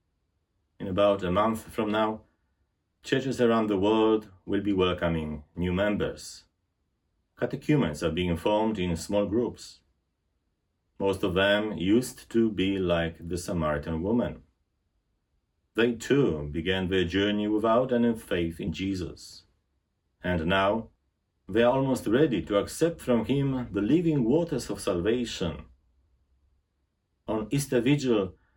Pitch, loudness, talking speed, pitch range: 95 Hz, -27 LUFS, 125 wpm, 85-110 Hz